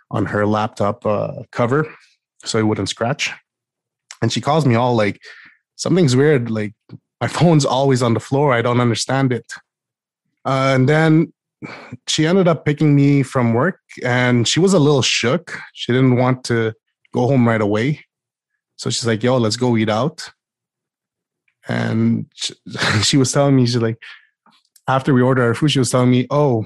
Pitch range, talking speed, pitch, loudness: 115-140 Hz, 175 wpm, 125 Hz, -17 LUFS